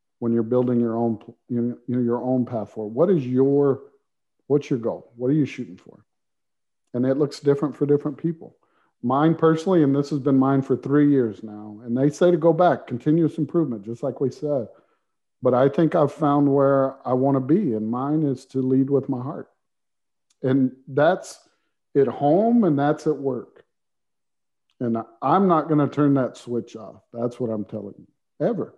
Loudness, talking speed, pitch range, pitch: -22 LUFS, 195 wpm, 120-145 Hz, 135 Hz